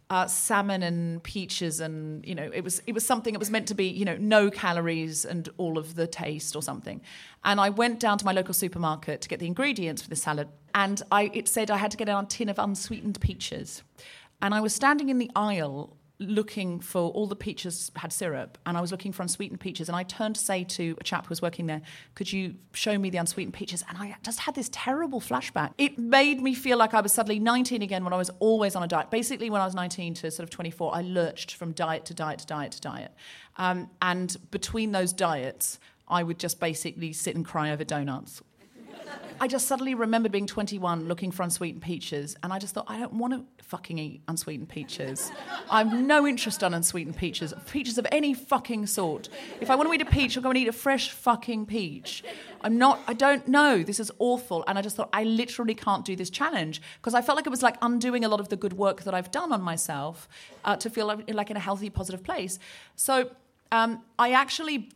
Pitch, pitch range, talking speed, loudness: 200 Hz, 170-230 Hz, 235 wpm, -28 LUFS